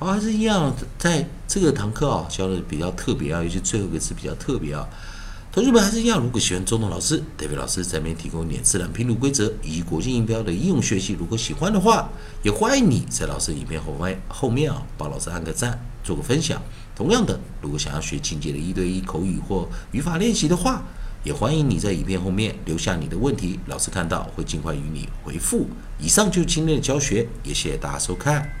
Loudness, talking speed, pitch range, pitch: -23 LUFS, 350 characters per minute, 90-145 Hz, 110 Hz